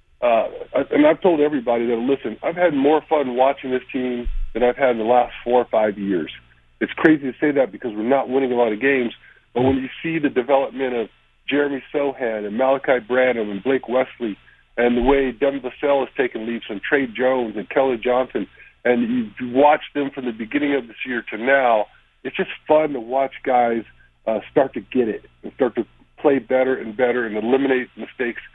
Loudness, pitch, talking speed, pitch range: -20 LUFS, 130 Hz, 205 wpm, 120-140 Hz